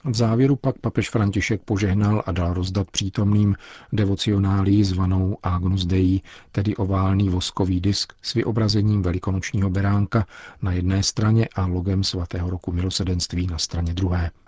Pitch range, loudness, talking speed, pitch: 90-105 Hz, -22 LUFS, 135 wpm, 95 Hz